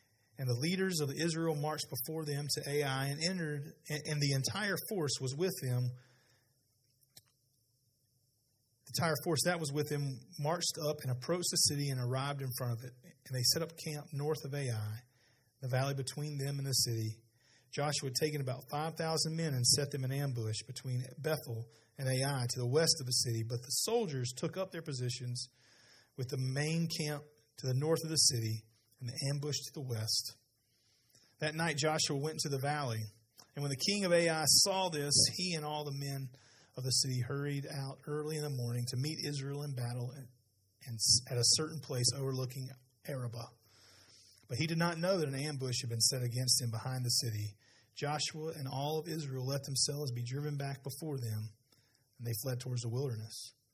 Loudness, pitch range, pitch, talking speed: -35 LUFS, 125-150 Hz, 135 Hz, 190 wpm